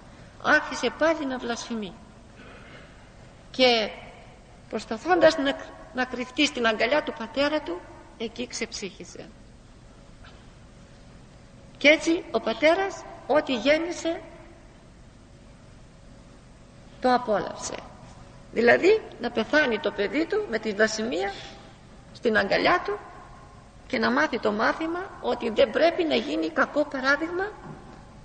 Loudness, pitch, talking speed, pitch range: -25 LUFS, 290 Hz, 100 wpm, 235-330 Hz